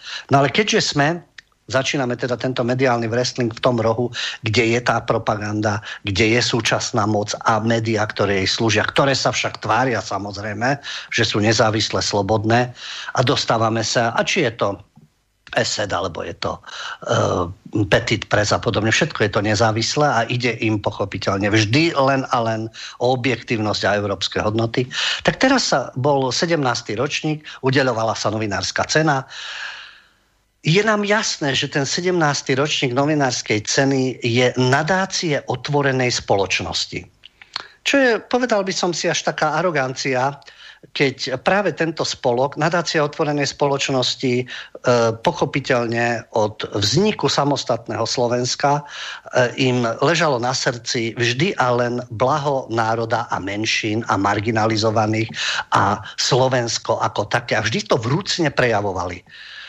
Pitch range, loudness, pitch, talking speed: 110-140 Hz, -19 LUFS, 125 Hz, 135 wpm